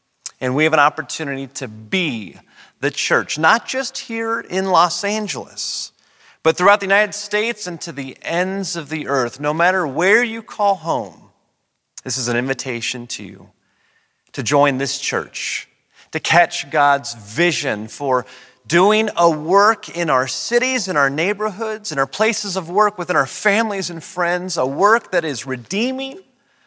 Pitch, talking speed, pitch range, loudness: 170 Hz, 160 wpm, 135-205 Hz, -18 LUFS